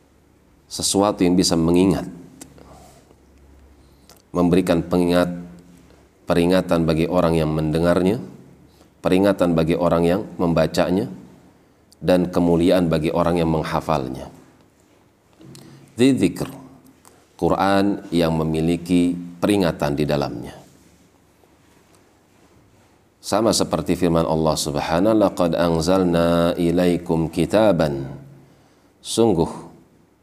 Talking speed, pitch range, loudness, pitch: 80 wpm, 80-90 Hz, -19 LUFS, 85 Hz